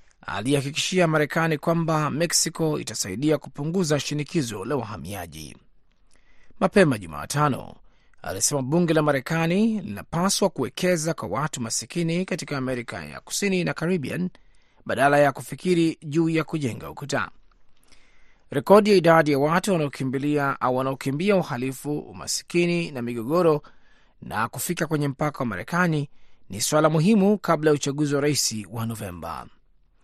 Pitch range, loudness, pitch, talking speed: 130-170 Hz, -23 LUFS, 150 Hz, 120 wpm